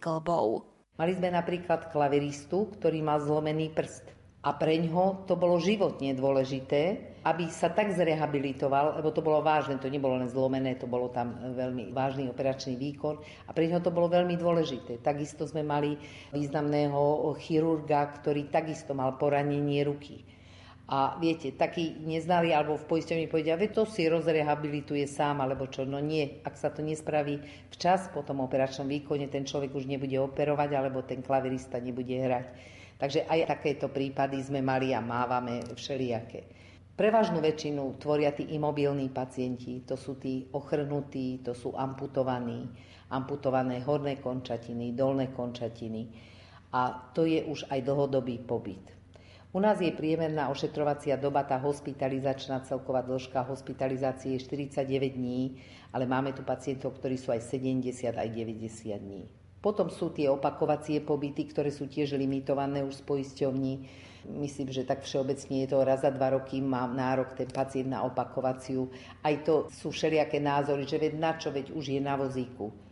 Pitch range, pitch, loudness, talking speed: 130-150 Hz, 140 Hz, -31 LUFS, 155 wpm